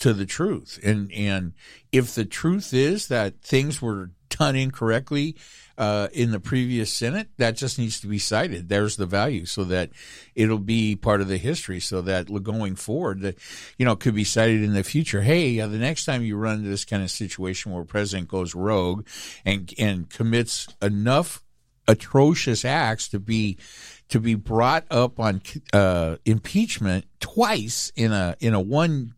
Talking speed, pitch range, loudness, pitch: 175 wpm, 100-125 Hz, -24 LUFS, 110 Hz